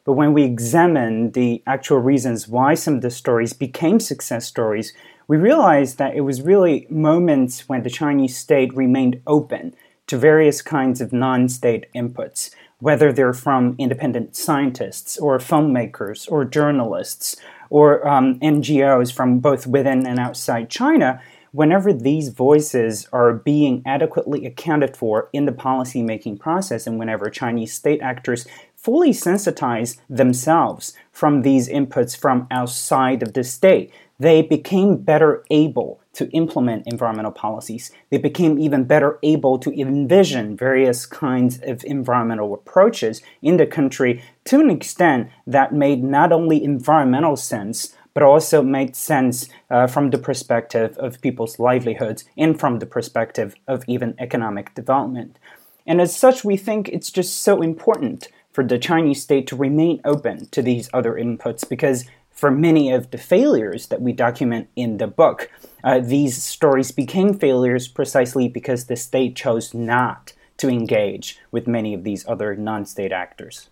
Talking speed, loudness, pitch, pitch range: 150 wpm, -18 LUFS, 130 Hz, 125-150 Hz